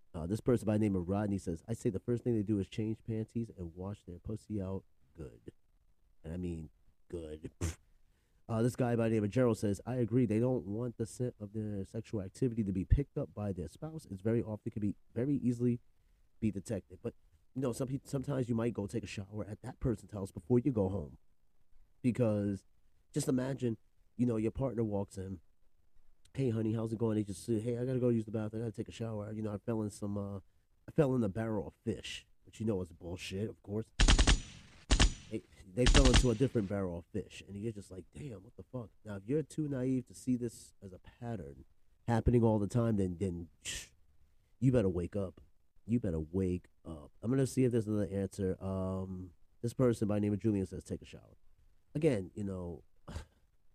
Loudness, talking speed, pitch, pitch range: -35 LUFS, 225 wpm, 105 Hz, 95-115 Hz